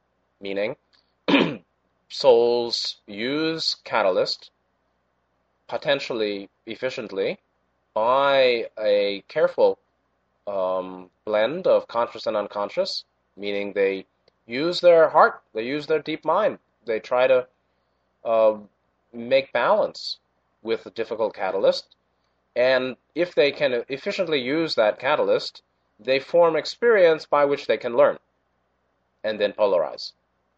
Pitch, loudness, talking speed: 115 Hz, -22 LUFS, 105 wpm